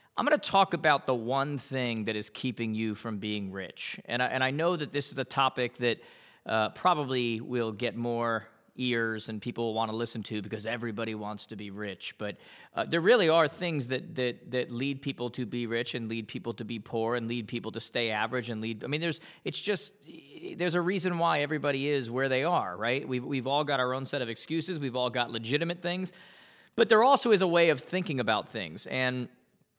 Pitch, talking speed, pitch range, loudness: 125 Hz, 230 wpm, 115-150 Hz, -30 LUFS